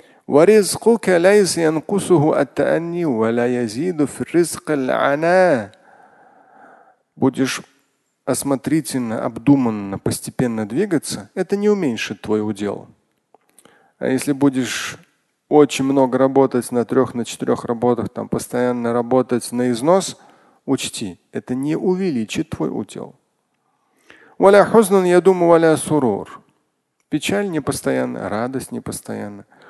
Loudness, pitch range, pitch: -18 LUFS, 120-170 Hz, 135 Hz